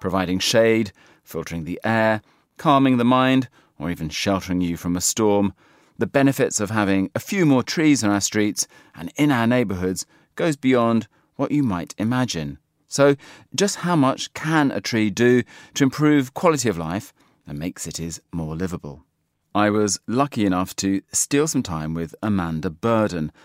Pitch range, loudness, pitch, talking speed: 95-130 Hz, -21 LUFS, 110 Hz, 165 wpm